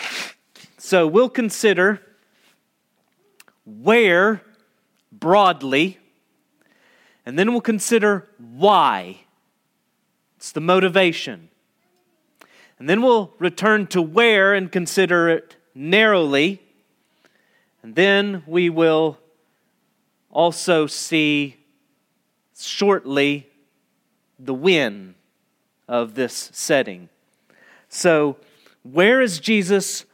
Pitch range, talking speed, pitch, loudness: 160-215 Hz, 80 wpm, 185 Hz, -18 LUFS